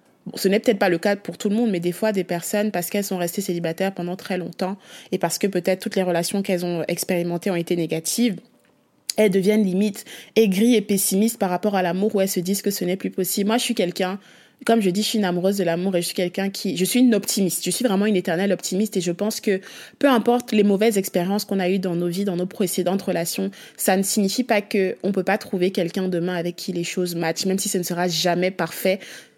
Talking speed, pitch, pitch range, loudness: 255 wpm, 190 Hz, 180-210 Hz, -22 LUFS